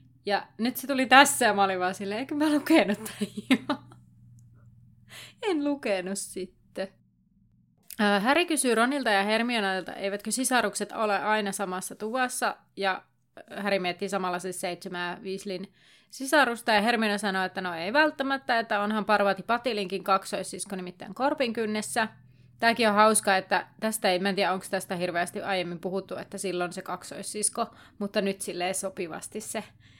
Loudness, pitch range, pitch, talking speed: -27 LUFS, 190-230 Hz, 200 Hz, 150 wpm